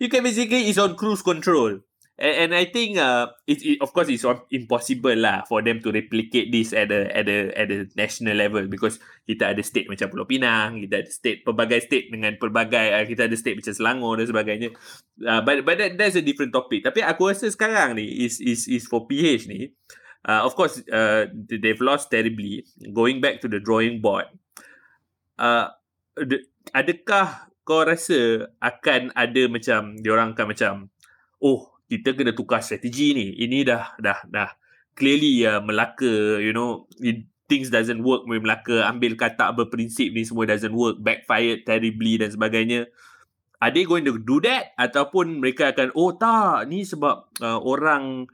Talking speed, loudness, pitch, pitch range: 180 wpm, -22 LUFS, 120 Hz, 110-145 Hz